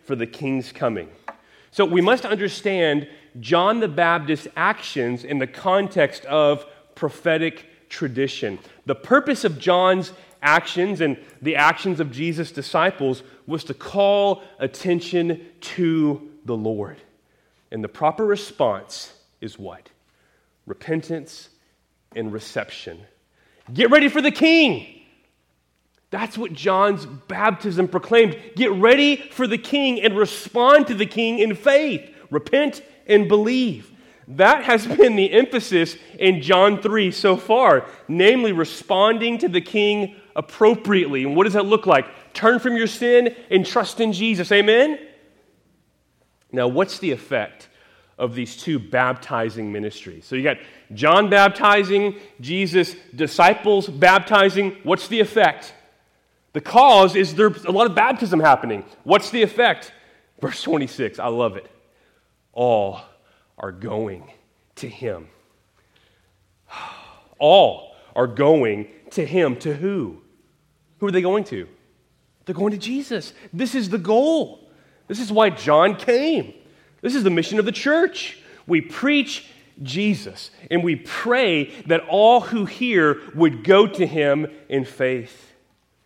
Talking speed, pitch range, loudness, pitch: 135 wpm, 150-220 Hz, -19 LUFS, 185 Hz